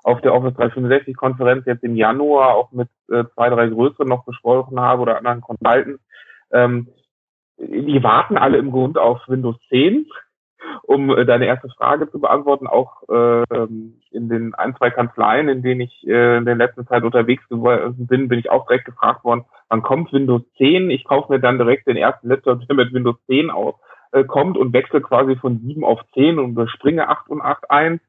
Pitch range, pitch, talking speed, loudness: 120-130 Hz, 125 Hz, 190 wpm, -17 LUFS